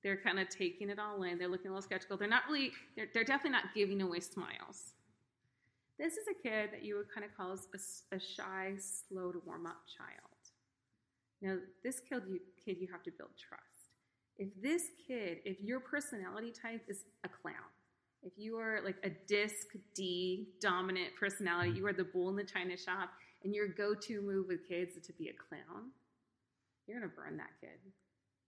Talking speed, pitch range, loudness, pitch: 195 wpm, 185-215 Hz, -40 LUFS, 195 Hz